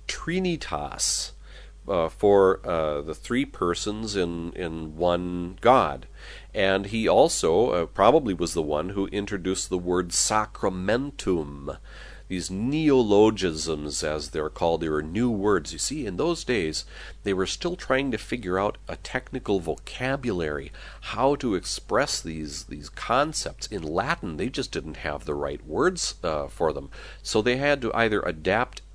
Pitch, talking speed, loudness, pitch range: 95 Hz, 150 wpm, -25 LUFS, 80-115 Hz